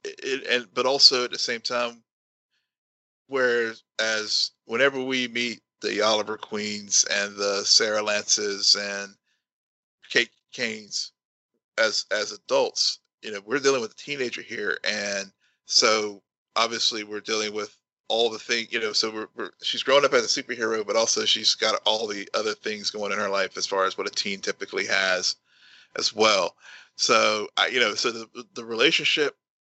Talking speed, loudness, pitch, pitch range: 175 wpm, -23 LUFS, 110 Hz, 105-125 Hz